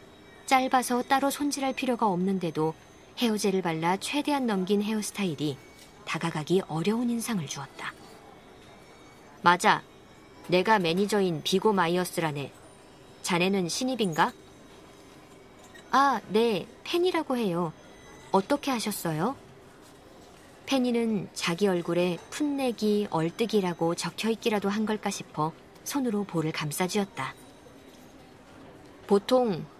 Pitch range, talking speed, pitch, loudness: 170-235 Hz, 245 characters per minute, 200 Hz, -28 LUFS